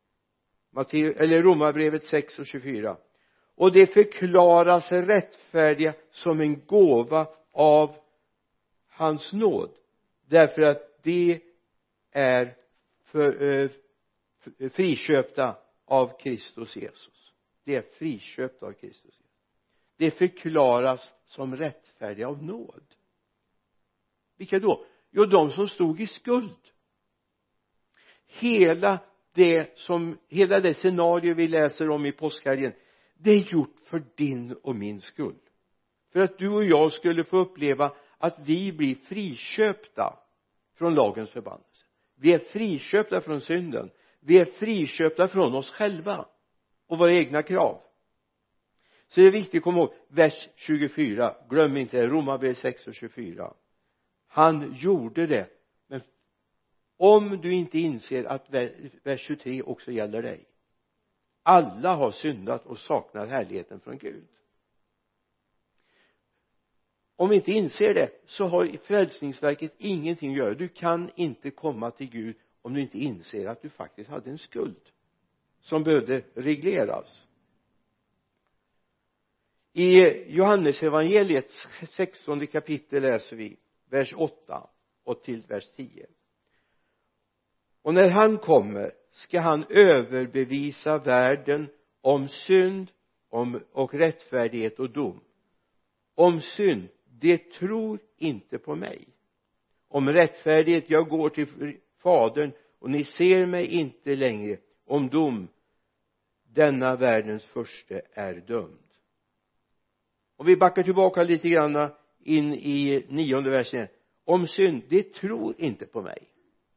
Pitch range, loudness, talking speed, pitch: 135-180 Hz, -24 LUFS, 120 wpm, 155 Hz